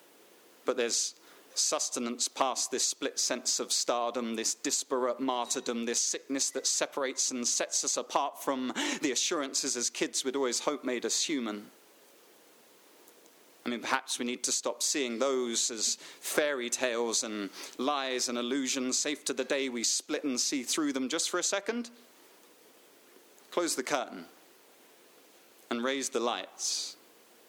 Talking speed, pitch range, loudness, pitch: 150 wpm, 120-155 Hz, -31 LUFS, 130 Hz